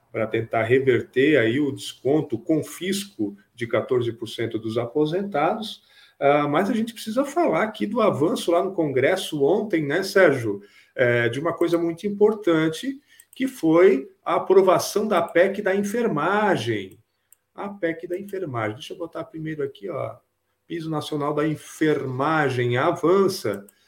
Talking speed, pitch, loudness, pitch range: 140 wpm, 165 Hz, -22 LUFS, 135-195 Hz